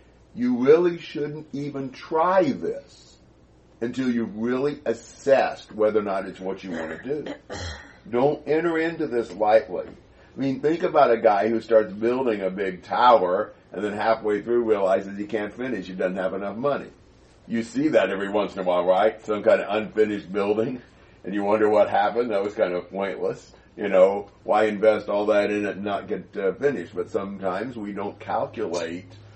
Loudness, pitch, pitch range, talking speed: -24 LUFS, 105 Hz, 100-125 Hz, 185 wpm